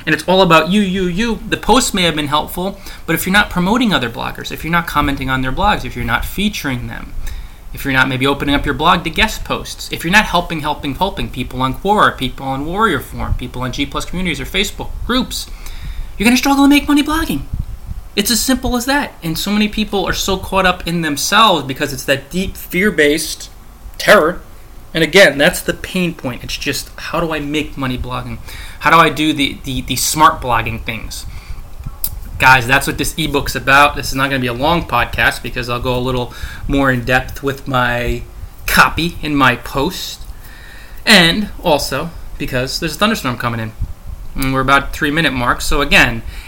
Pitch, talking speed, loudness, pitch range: 145 Hz, 210 wpm, -15 LUFS, 125-180 Hz